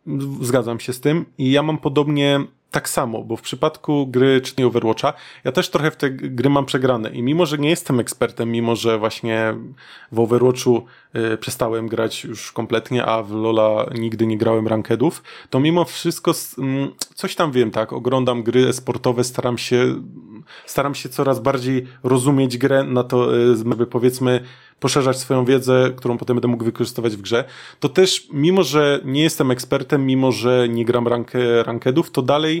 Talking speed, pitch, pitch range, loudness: 180 wpm, 125 Hz, 120-140 Hz, -19 LUFS